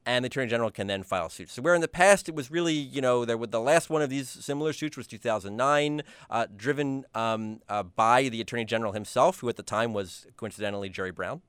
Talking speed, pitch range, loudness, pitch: 235 wpm, 110-145 Hz, -28 LUFS, 125 Hz